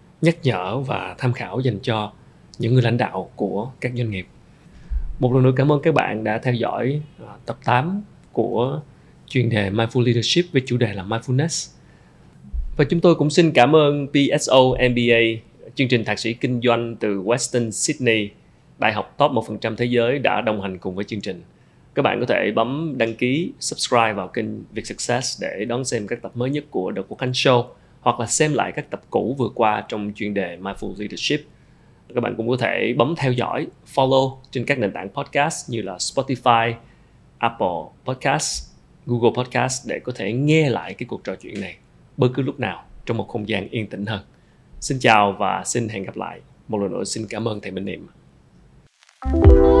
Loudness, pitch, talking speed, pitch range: -21 LUFS, 120 Hz, 200 wpm, 110-130 Hz